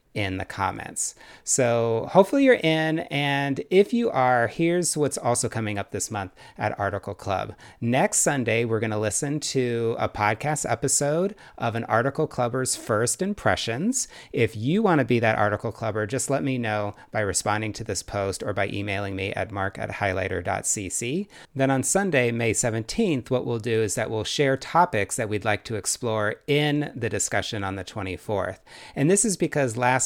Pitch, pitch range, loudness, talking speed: 115 Hz, 105-145 Hz, -24 LUFS, 180 wpm